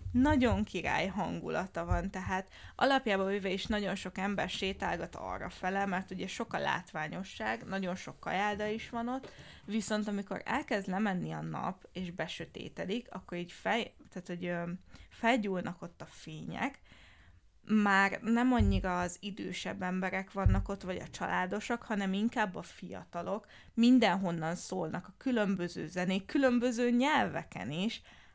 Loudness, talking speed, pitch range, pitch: -34 LUFS, 140 wpm, 180-215 Hz, 195 Hz